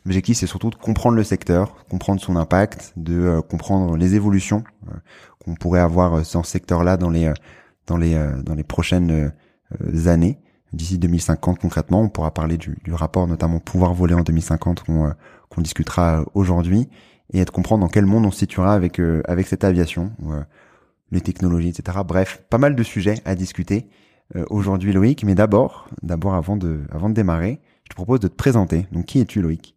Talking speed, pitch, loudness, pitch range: 200 wpm, 90 Hz, -20 LUFS, 85-100 Hz